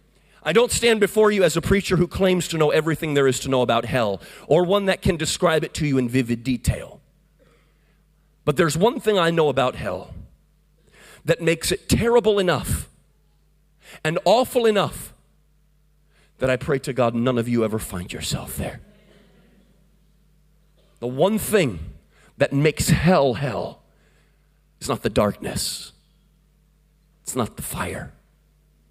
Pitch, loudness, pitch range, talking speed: 160 Hz, -21 LUFS, 135-185 Hz, 150 wpm